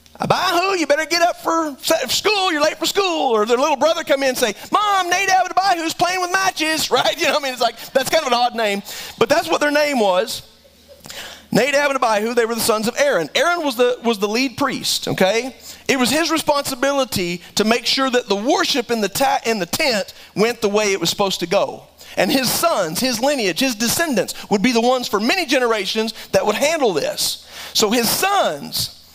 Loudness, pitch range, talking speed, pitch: -18 LUFS, 230-320 Hz, 220 wpm, 265 Hz